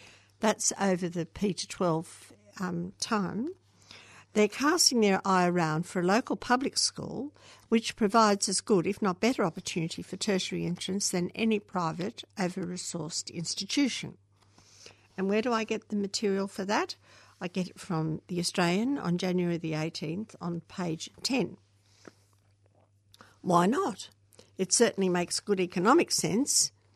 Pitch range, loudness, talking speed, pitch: 165-210 Hz, -29 LUFS, 140 wpm, 185 Hz